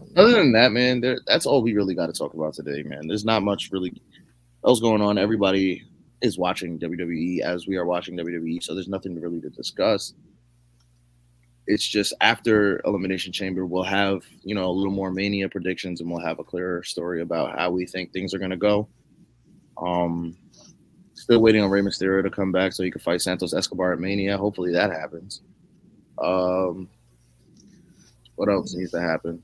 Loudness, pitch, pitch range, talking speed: -23 LUFS, 90 Hz, 85-100 Hz, 190 wpm